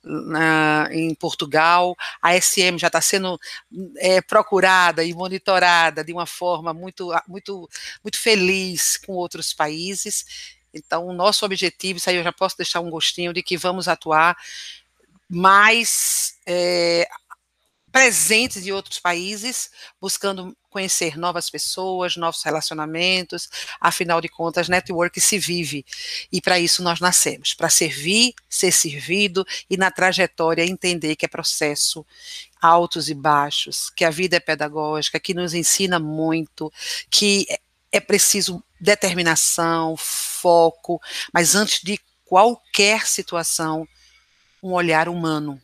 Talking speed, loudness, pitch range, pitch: 130 wpm, -19 LUFS, 165-190 Hz, 175 Hz